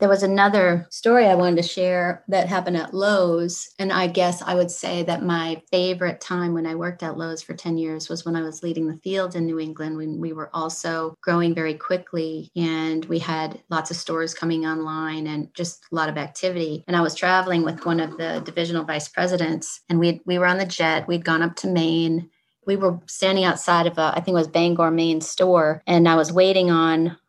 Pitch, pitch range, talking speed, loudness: 170 Hz, 160-180 Hz, 225 wpm, -22 LUFS